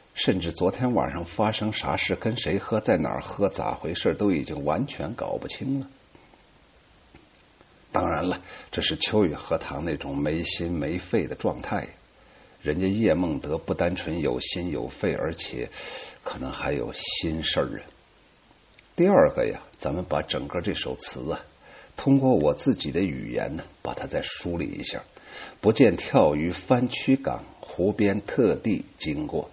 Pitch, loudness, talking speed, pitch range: 95 Hz, -26 LUFS, 225 characters per minute, 80-125 Hz